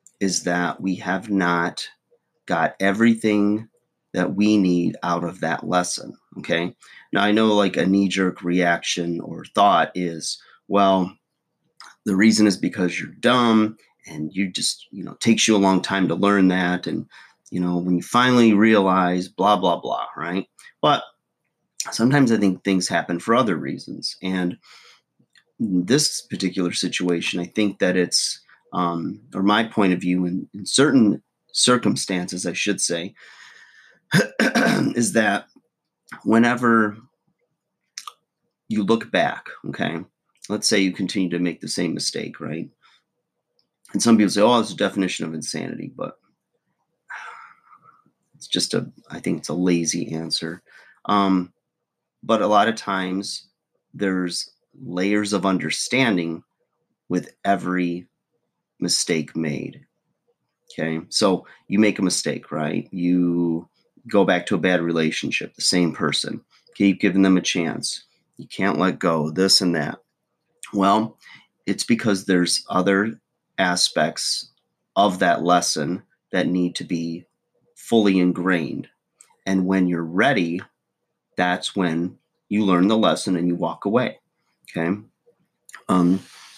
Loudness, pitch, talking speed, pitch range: -21 LUFS, 95 Hz, 140 wpm, 90-100 Hz